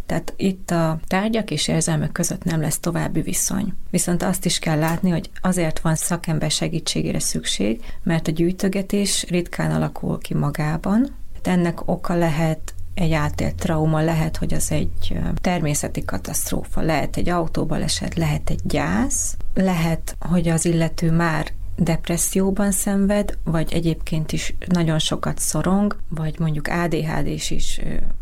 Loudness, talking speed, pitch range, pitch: -22 LUFS, 140 wpm, 155-180 Hz, 165 Hz